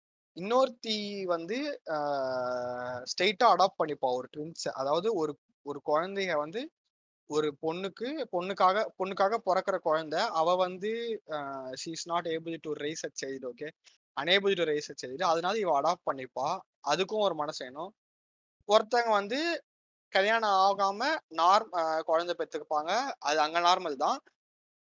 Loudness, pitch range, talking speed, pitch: -30 LUFS, 150-210 Hz, 120 wpm, 175 Hz